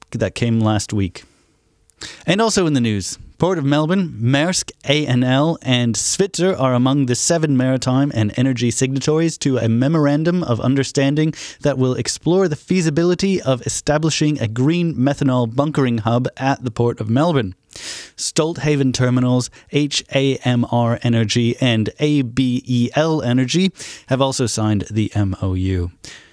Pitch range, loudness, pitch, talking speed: 120-150 Hz, -18 LUFS, 130 Hz, 130 wpm